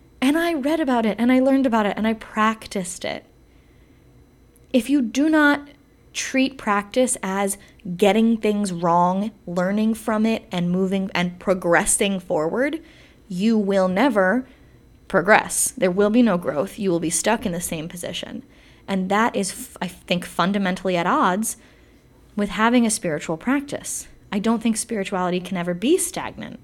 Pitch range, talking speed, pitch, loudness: 185-240 Hz, 160 wpm, 210 Hz, -21 LUFS